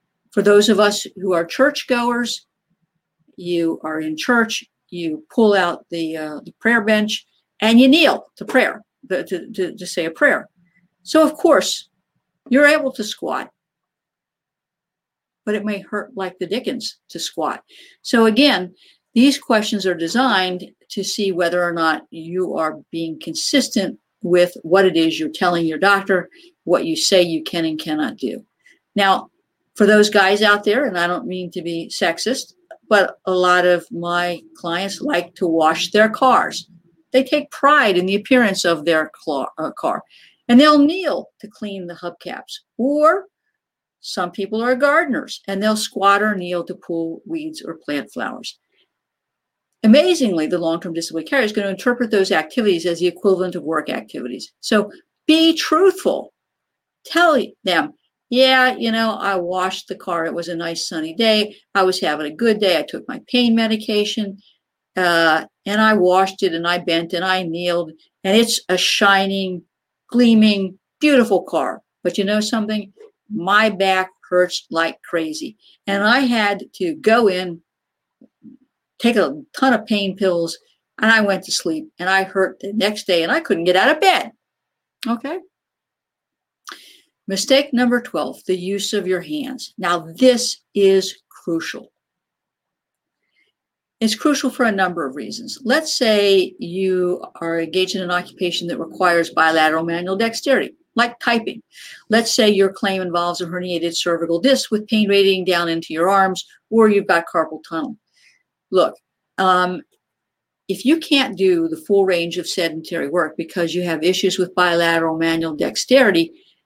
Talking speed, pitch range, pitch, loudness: 160 wpm, 175-235 Hz, 195 Hz, -18 LUFS